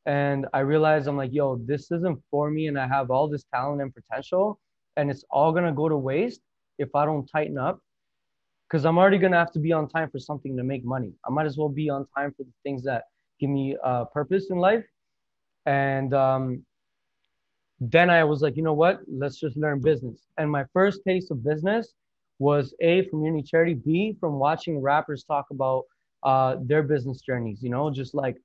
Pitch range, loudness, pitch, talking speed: 135-160 Hz, -25 LUFS, 145 Hz, 215 wpm